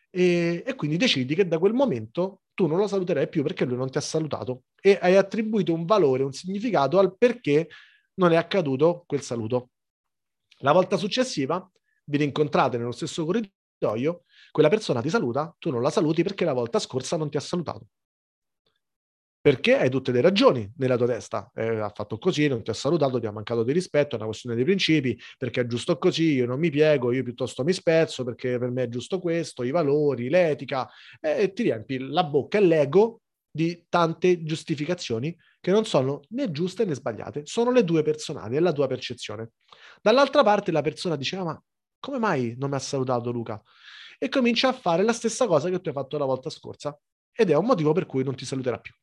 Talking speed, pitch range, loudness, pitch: 205 wpm, 130-185 Hz, -24 LUFS, 155 Hz